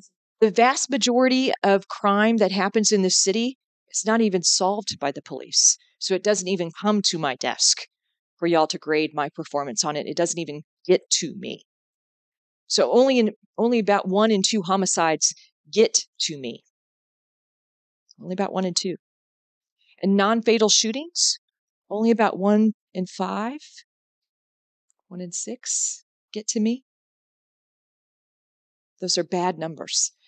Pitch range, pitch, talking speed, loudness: 180-230 Hz, 200 Hz, 150 wpm, -22 LUFS